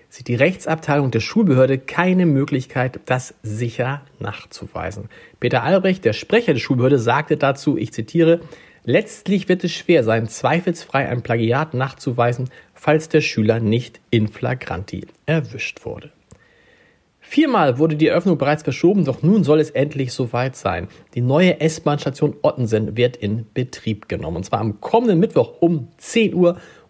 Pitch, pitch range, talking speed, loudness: 140 Hz, 125-170 Hz, 145 wpm, -19 LUFS